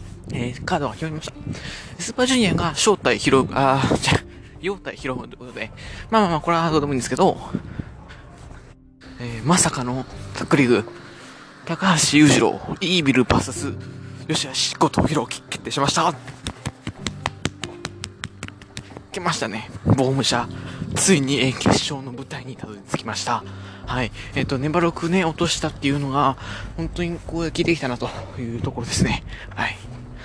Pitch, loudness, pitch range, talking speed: 130 Hz, -21 LUFS, 115-160 Hz, 310 characters per minute